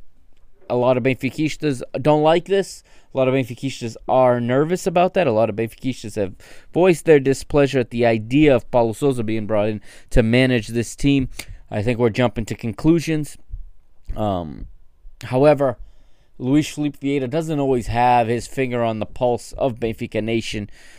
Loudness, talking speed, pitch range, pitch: -20 LUFS, 165 wpm, 110-140 Hz, 125 Hz